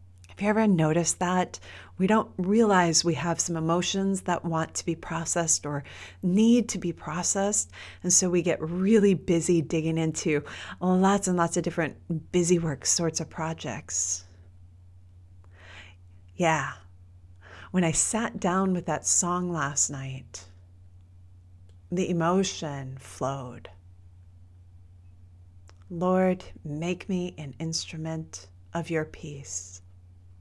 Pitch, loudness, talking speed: 160 Hz, -26 LUFS, 120 wpm